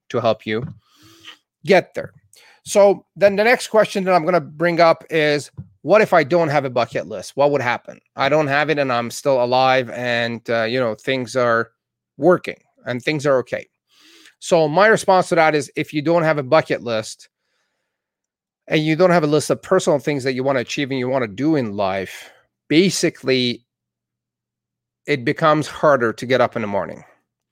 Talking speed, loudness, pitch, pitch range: 200 wpm, -18 LUFS, 145 Hz, 125-165 Hz